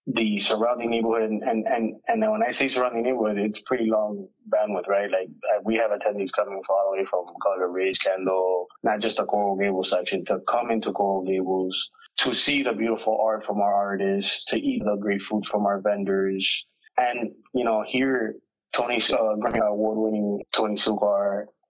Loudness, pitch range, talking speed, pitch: -24 LUFS, 100-115 Hz, 190 wpm, 105 Hz